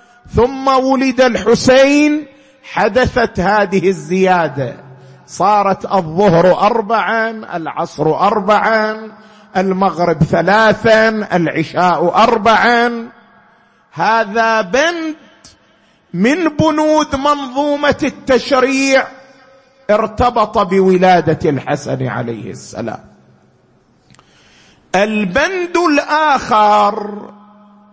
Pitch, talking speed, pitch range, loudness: 220 Hz, 60 wpm, 195-260 Hz, -13 LUFS